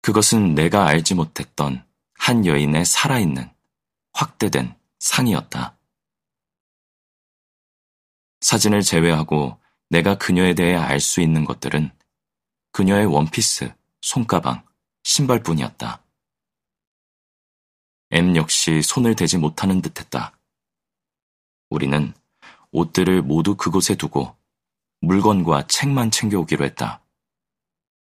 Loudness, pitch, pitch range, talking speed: -19 LUFS, 85 Hz, 75-100 Hz, 210 characters per minute